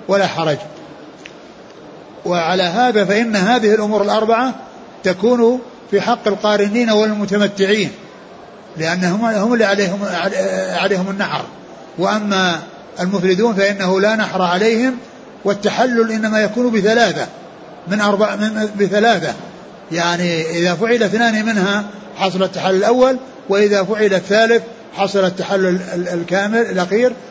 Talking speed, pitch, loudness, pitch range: 105 wpm, 205 Hz, -16 LUFS, 185-225 Hz